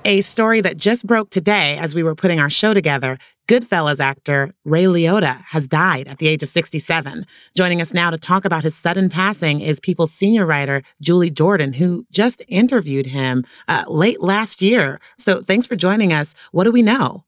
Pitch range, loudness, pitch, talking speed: 155-205 Hz, -17 LUFS, 175 Hz, 195 wpm